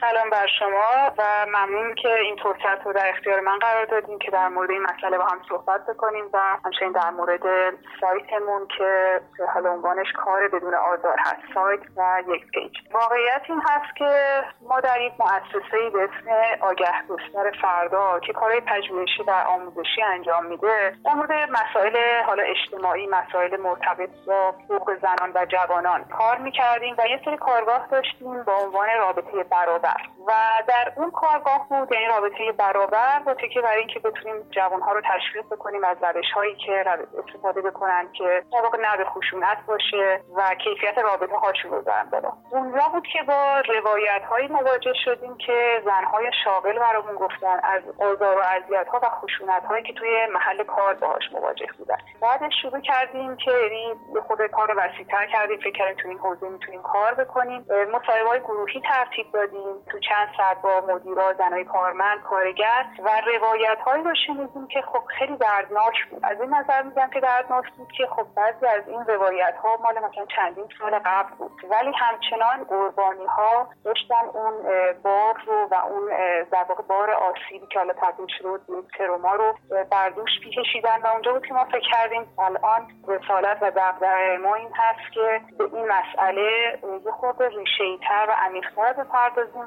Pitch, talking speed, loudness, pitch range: 210 Hz, 170 wpm, -23 LUFS, 190-240 Hz